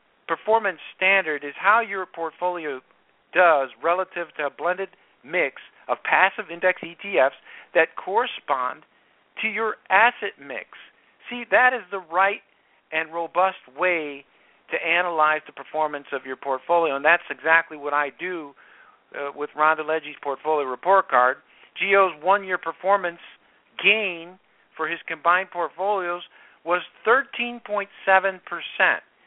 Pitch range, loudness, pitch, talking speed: 155-195 Hz, -23 LUFS, 175 Hz, 125 wpm